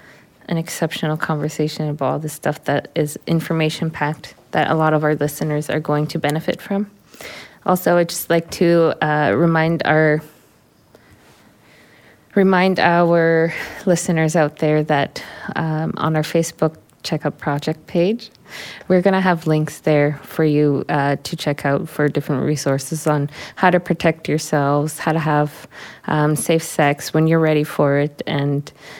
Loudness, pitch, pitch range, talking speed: -19 LUFS, 155 Hz, 150-170 Hz, 155 wpm